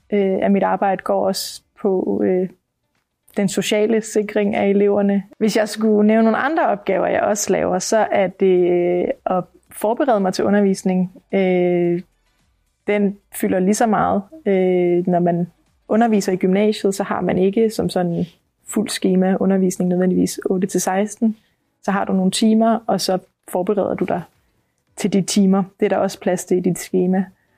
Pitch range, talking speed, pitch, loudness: 185-210 Hz, 170 wpm, 195 Hz, -18 LUFS